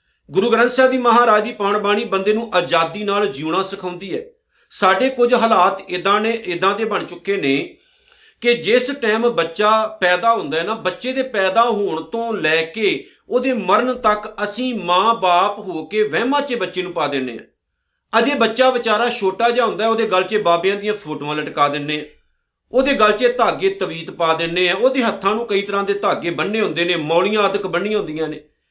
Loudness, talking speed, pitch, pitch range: -18 LUFS, 190 wpm, 205 Hz, 180-235 Hz